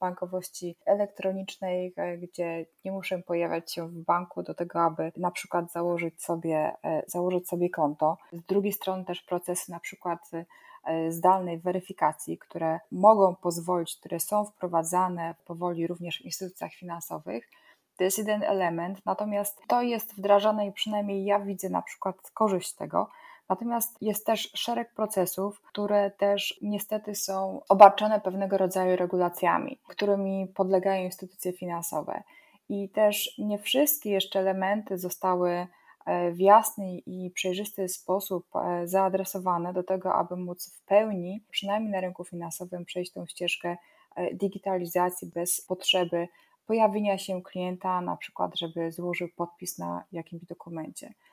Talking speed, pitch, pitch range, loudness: 130 wpm, 185 Hz, 175-200 Hz, -28 LUFS